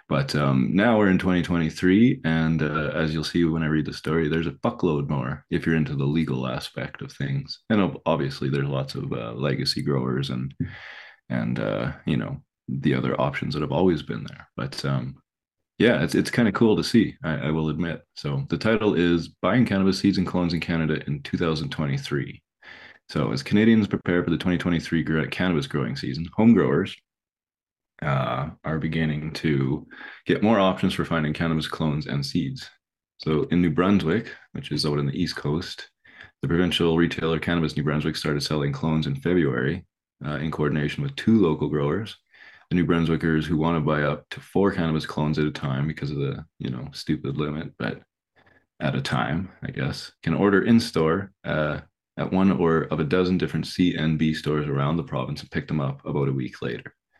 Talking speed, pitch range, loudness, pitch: 190 wpm, 75-90 Hz, -24 LUFS, 80 Hz